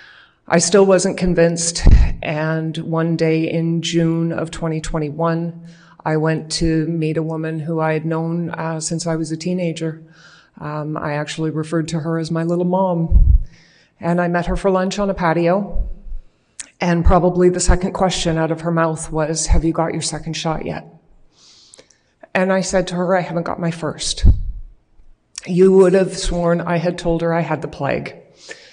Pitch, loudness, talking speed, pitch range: 165 Hz, -18 LUFS, 180 wpm, 160-175 Hz